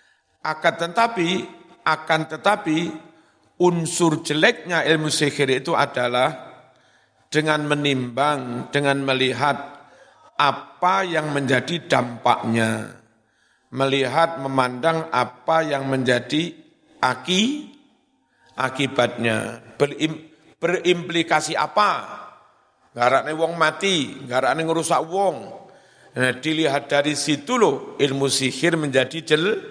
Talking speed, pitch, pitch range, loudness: 85 wpm, 150 Hz, 130-165 Hz, -21 LUFS